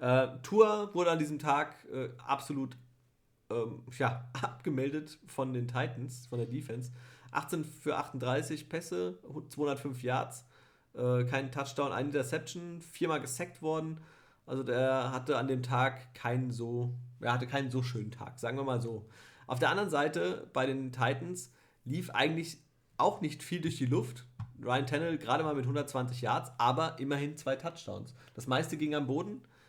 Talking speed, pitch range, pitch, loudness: 160 wpm, 125-150 Hz, 135 Hz, -34 LUFS